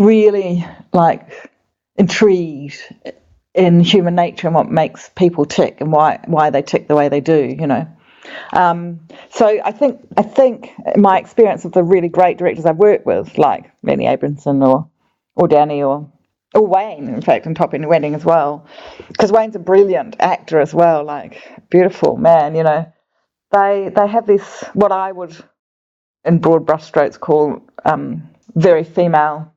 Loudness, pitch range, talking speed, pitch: -14 LUFS, 150-200 Hz, 165 wpm, 170 Hz